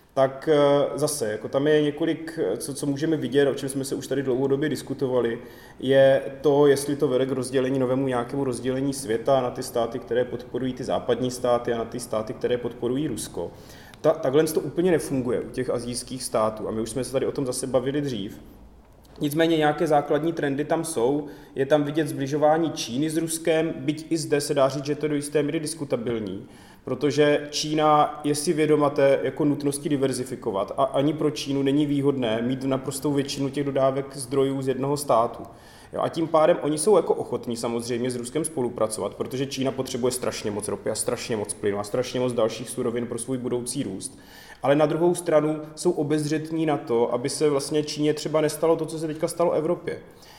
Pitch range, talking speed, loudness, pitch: 125-150 Hz, 195 wpm, -24 LUFS, 140 Hz